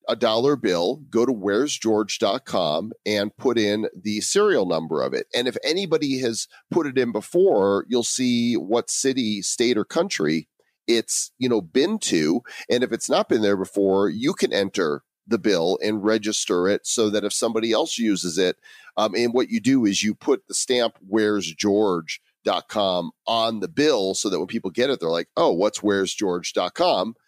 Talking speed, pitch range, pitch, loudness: 180 wpm, 100-120 Hz, 110 Hz, -22 LUFS